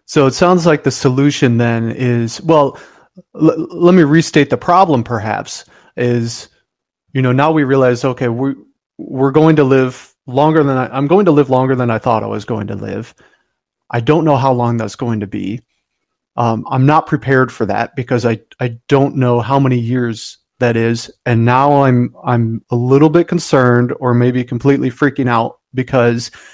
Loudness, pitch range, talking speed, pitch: -13 LUFS, 120-145 Hz, 190 wpm, 130 Hz